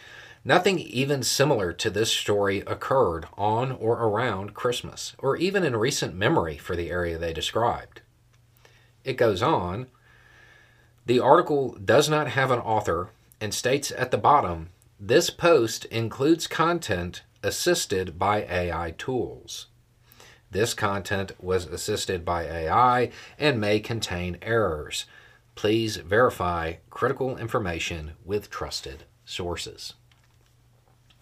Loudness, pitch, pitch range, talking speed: -25 LUFS, 115 Hz, 95-125 Hz, 115 wpm